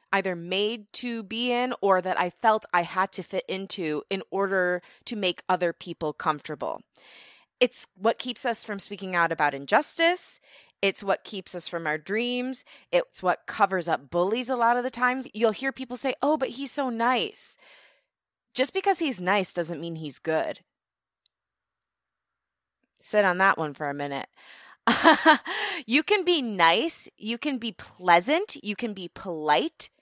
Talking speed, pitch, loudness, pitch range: 165 wpm, 210 Hz, -26 LUFS, 180-250 Hz